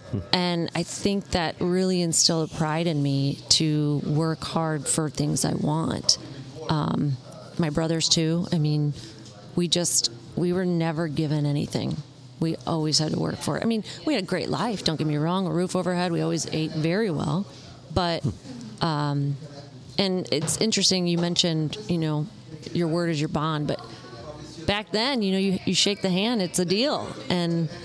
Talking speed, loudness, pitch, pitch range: 180 wpm, -25 LUFS, 160 Hz, 150-180 Hz